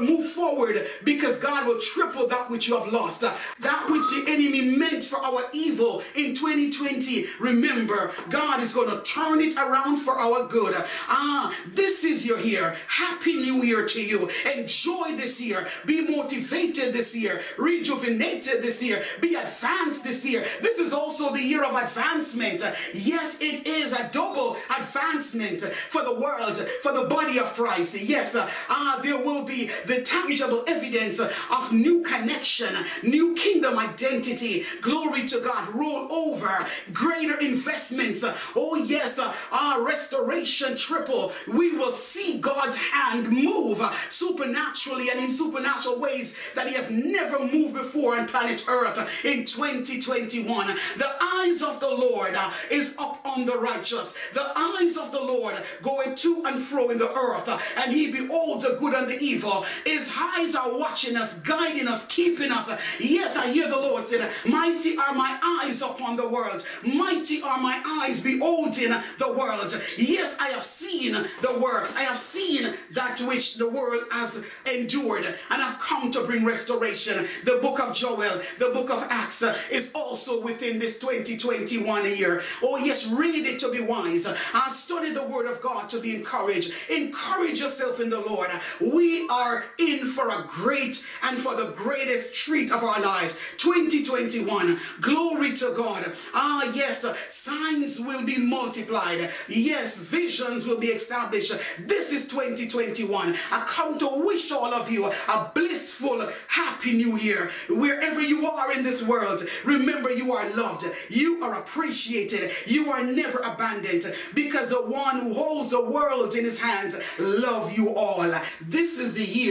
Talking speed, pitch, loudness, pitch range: 160 wpm, 265 Hz, -24 LUFS, 240-310 Hz